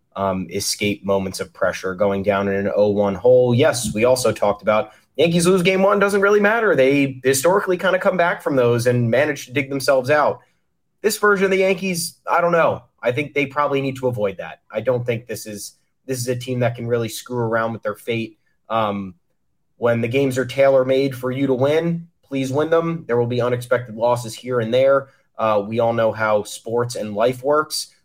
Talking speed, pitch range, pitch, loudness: 220 wpm, 110-150 Hz, 125 Hz, -19 LUFS